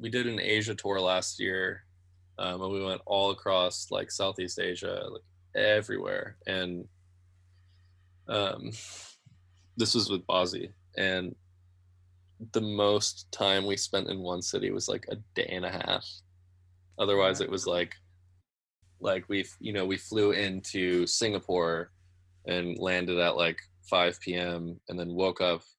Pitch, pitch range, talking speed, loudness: 90 Hz, 90-100 Hz, 145 wpm, -30 LUFS